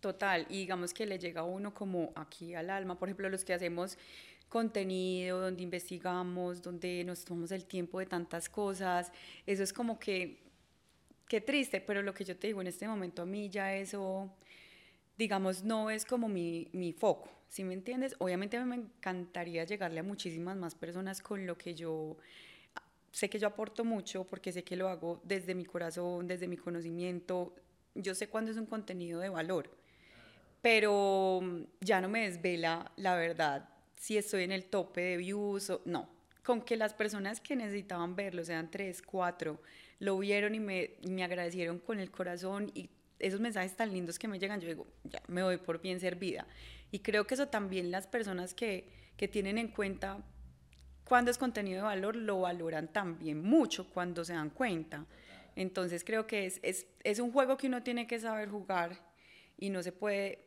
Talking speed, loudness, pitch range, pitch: 190 wpm, -37 LUFS, 175-205 Hz, 190 Hz